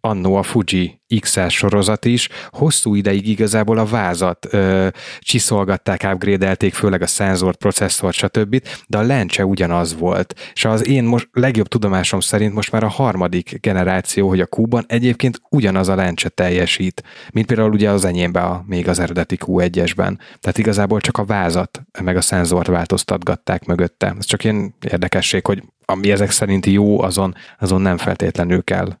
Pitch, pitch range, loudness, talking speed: 100 Hz, 90-110 Hz, -17 LUFS, 160 wpm